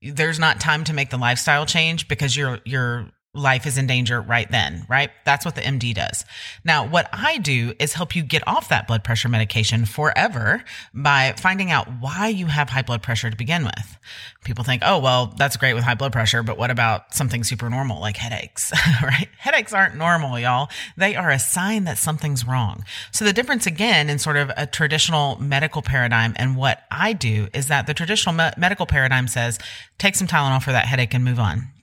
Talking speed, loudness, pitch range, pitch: 210 wpm, -20 LUFS, 120-155 Hz, 135 Hz